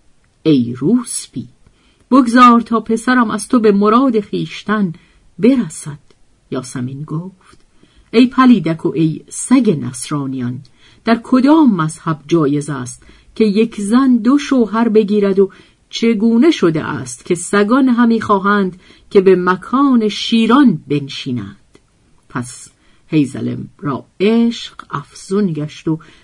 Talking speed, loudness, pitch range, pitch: 115 wpm, -14 LUFS, 150-230 Hz, 195 Hz